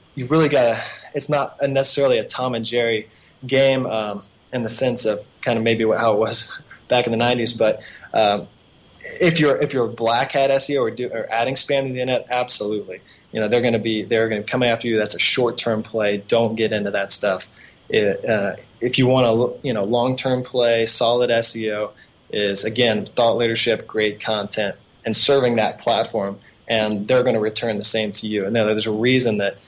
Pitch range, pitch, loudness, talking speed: 110-125 Hz, 115 Hz, -20 LUFS, 220 wpm